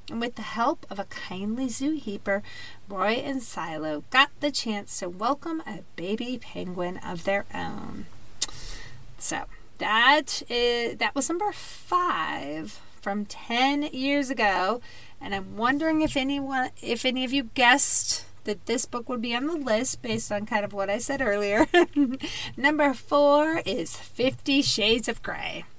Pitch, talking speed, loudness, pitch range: 240 Hz, 155 wpm, -25 LUFS, 205-280 Hz